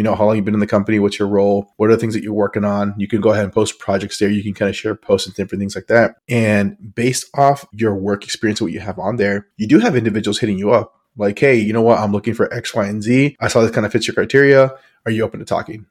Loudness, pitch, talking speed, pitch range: -16 LUFS, 105 Hz, 310 wpm, 100-115 Hz